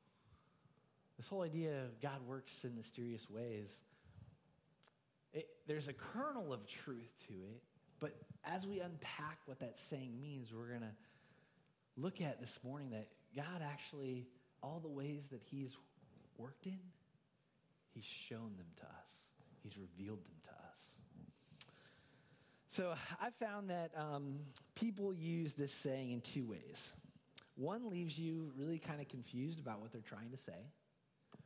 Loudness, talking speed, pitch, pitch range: -49 LUFS, 145 wpm, 145 Hz, 125-165 Hz